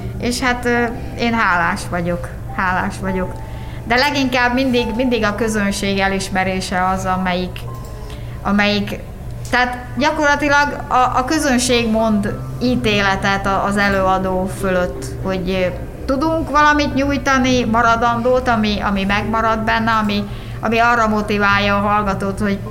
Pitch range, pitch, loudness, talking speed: 195-245 Hz, 215 Hz, -17 LUFS, 115 wpm